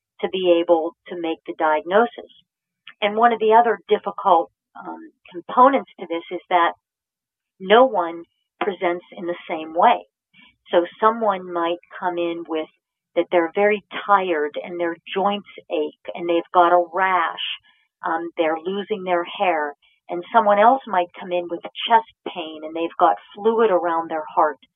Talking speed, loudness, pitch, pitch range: 160 wpm, -20 LUFS, 175 Hz, 170-205 Hz